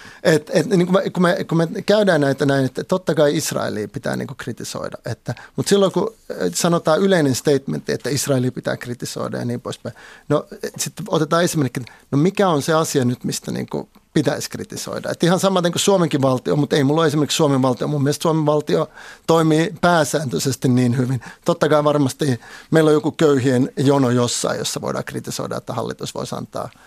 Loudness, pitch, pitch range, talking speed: -19 LUFS, 150 Hz, 135-170 Hz, 185 wpm